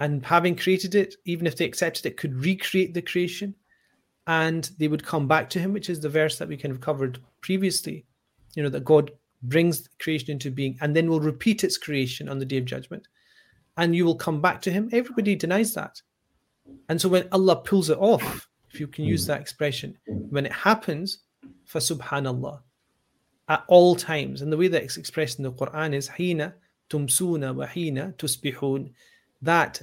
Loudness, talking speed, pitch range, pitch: -25 LUFS, 190 wpm, 145-180 Hz, 160 Hz